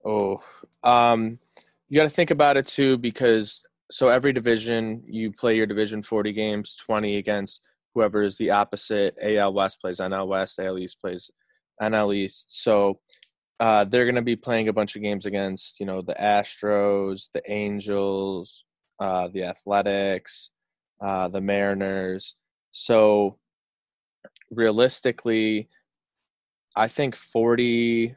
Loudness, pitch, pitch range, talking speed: -23 LUFS, 105 Hz, 100-115 Hz, 135 wpm